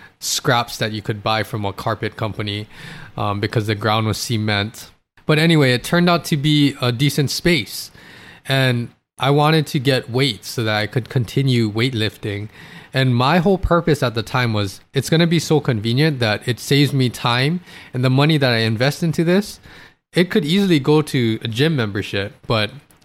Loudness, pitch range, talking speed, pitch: -18 LUFS, 110-150 Hz, 190 wpm, 130 Hz